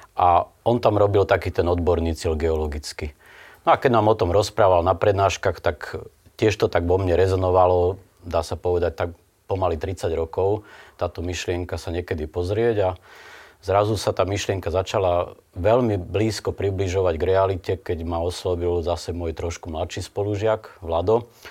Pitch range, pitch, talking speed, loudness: 85-100 Hz, 90 Hz, 160 wpm, -22 LUFS